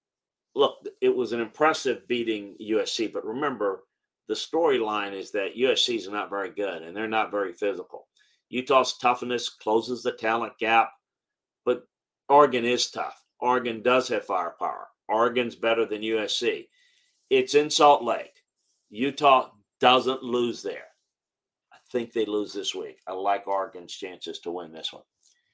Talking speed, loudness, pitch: 150 wpm, -26 LUFS, 125 Hz